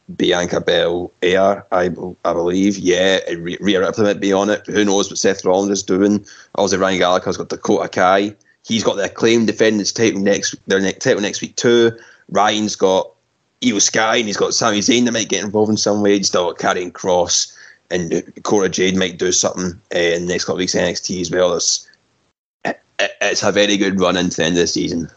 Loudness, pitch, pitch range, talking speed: -17 LUFS, 100 Hz, 90-105 Hz, 210 wpm